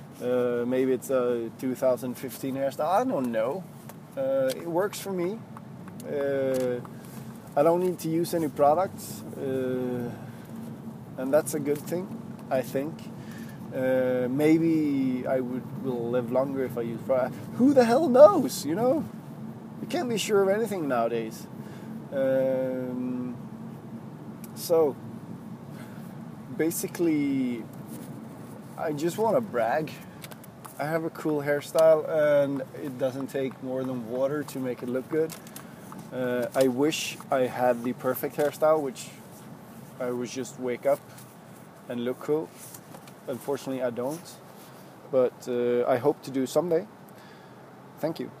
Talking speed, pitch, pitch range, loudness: 140 wpm, 135 Hz, 125-165 Hz, -27 LUFS